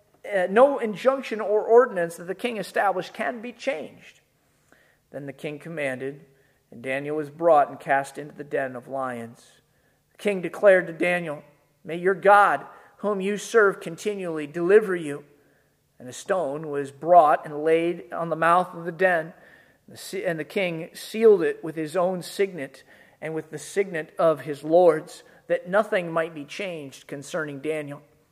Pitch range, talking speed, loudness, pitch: 145-195 Hz, 165 wpm, -24 LUFS, 165 Hz